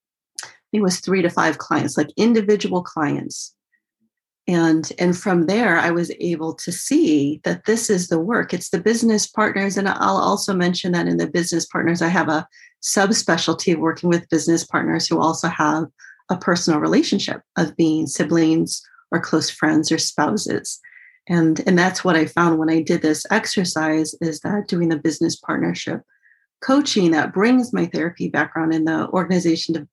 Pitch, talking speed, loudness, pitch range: 170 Hz, 170 wpm, -19 LUFS, 160-195 Hz